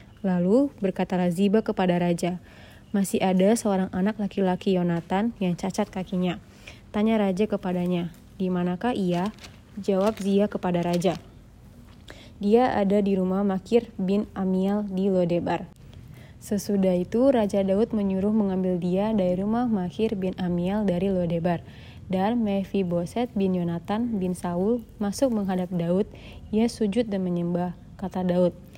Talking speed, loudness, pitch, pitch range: 130 wpm, -25 LUFS, 190 Hz, 180-205 Hz